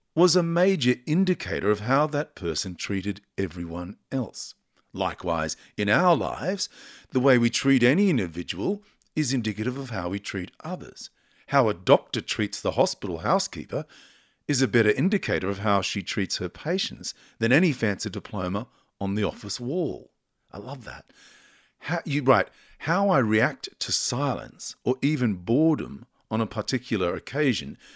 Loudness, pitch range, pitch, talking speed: -26 LUFS, 100-145 Hz, 115 Hz, 150 wpm